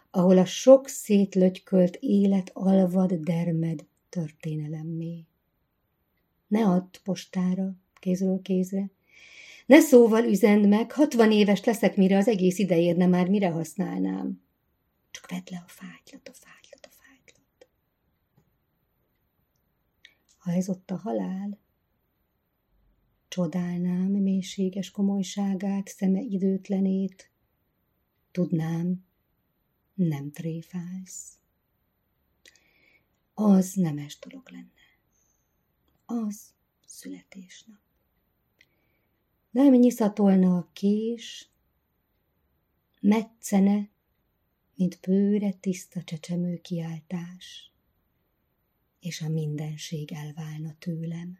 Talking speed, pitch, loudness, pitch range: 85 wpm, 185 Hz, -25 LUFS, 170-200 Hz